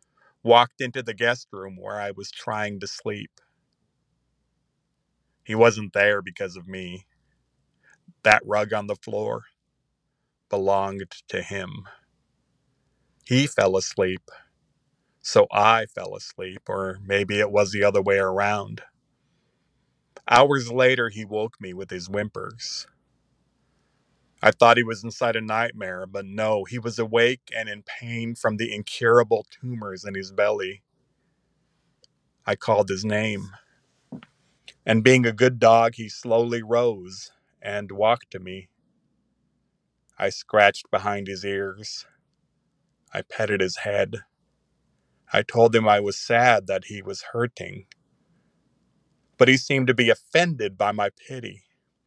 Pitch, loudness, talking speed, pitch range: 105 Hz, -22 LUFS, 130 wpm, 100-115 Hz